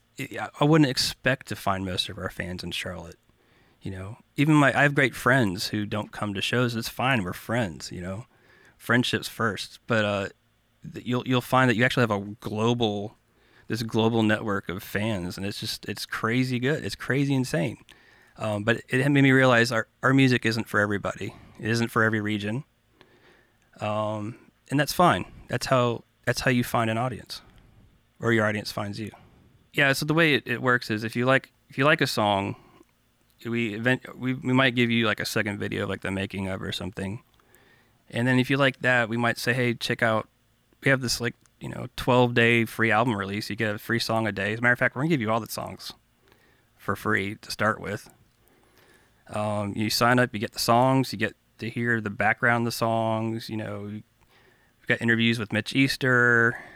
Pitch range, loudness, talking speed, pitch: 105-125 Hz, -25 LUFS, 205 wpm, 115 Hz